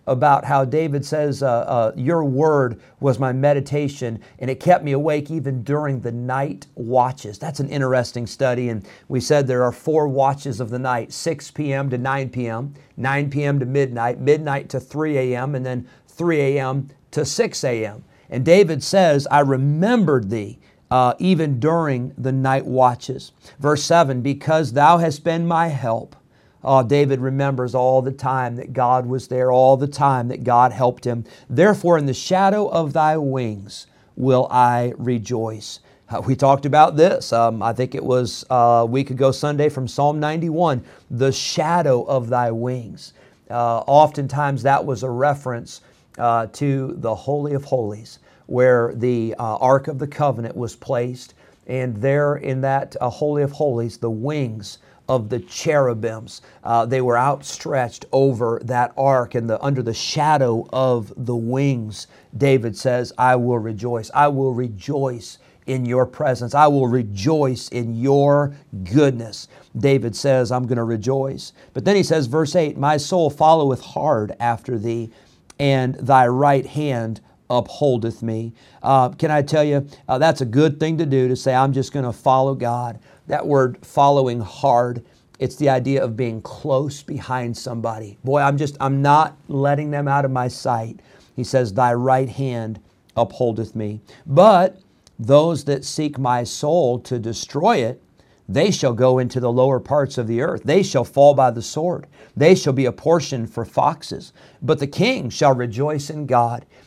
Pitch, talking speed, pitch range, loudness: 130 Hz, 170 wpm, 120-145 Hz, -19 LUFS